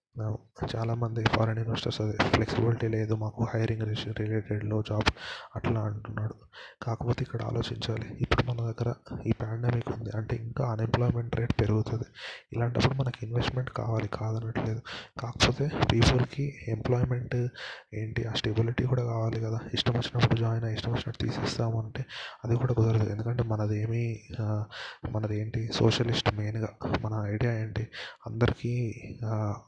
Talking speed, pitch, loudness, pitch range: 125 wpm, 115 Hz, -30 LUFS, 110-120 Hz